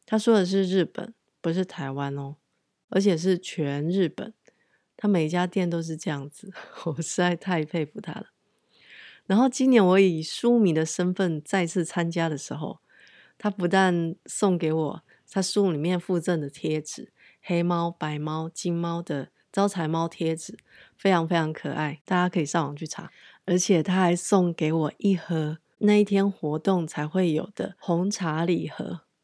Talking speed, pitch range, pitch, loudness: 240 characters per minute, 160-190 Hz, 175 Hz, -26 LUFS